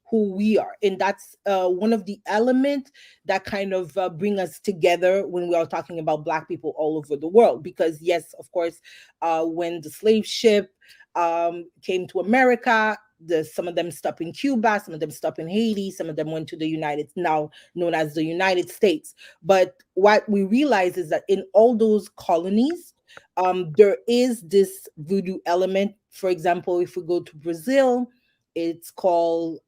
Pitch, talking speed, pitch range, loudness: 185 Hz, 185 wpm, 170-210 Hz, -22 LUFS